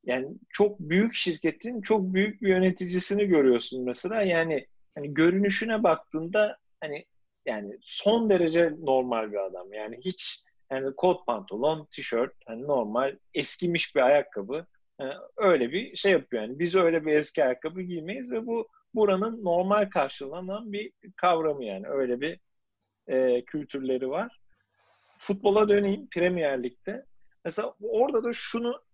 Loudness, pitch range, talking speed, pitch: -27 LUFS, 140-205 Hz, 135 wpm, 180 Hz